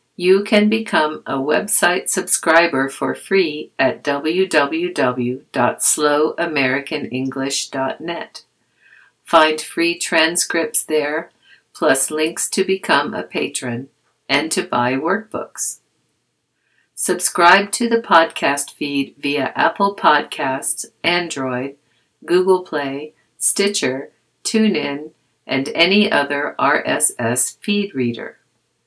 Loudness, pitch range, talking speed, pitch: -17 LUFS, 140-190 Hz, 90 wpm, 155 Hz